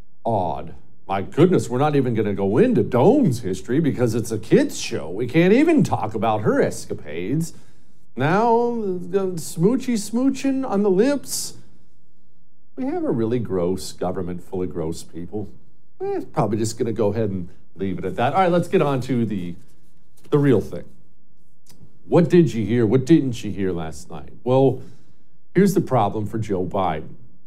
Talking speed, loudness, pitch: 175 wpm, -21 LUFS, 125 Hz